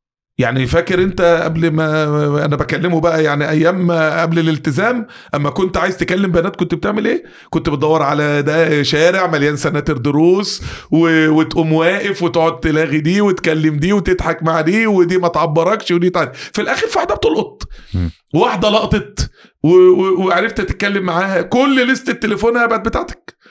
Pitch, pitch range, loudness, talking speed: 170 Hz, 155-190 Hz, -14 LUFS, 150 wpm